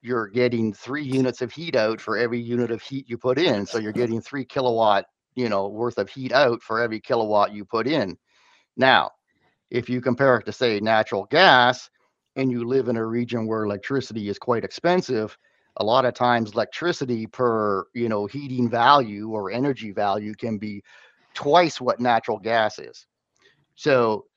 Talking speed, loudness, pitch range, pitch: 180 wpm, -23 LUFS, 110-130 Hz, 120 Hz